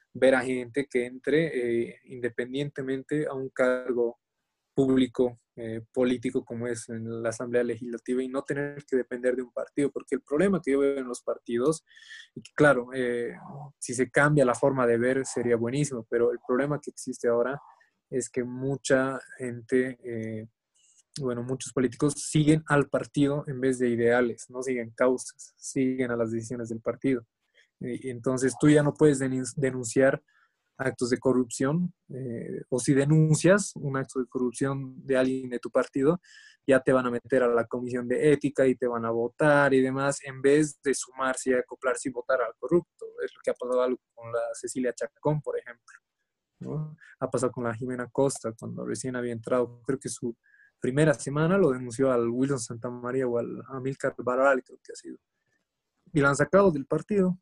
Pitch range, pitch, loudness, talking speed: 125-140 Hz, 130 Hz, -27 LUFS, 180 wpm